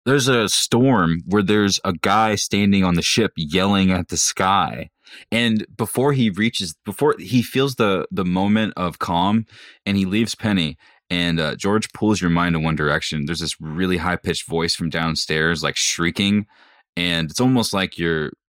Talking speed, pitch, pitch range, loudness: 180 wpm, 95 Hz, 85-110 Hz, -19 LUFS